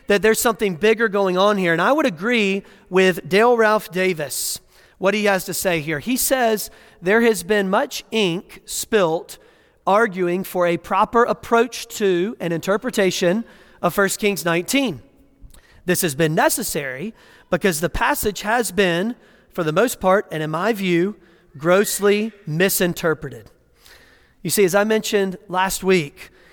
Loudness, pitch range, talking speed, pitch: -19 LUFS, 180-220 Hz, 150 wpm, 200 Hz